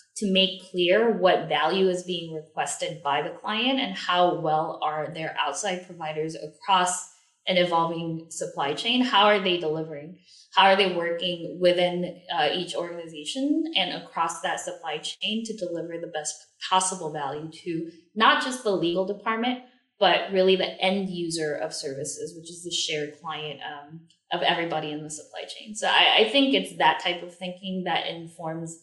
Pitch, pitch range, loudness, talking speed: 175 Hz, 160-190 Hz, -25 LUFS, 170 wpm